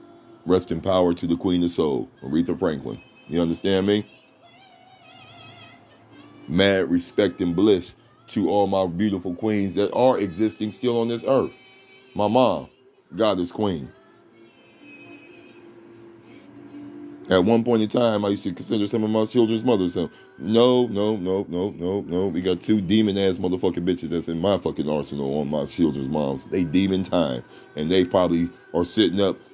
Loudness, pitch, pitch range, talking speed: -23 LUFS, 100 Hz, 90-115 Hz, 160 wpm